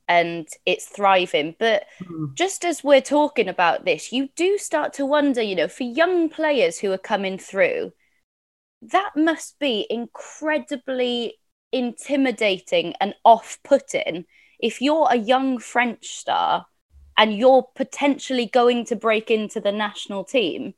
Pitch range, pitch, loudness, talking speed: 210-295 Hz, 250 Hz, -21 LUFS, 140 wpm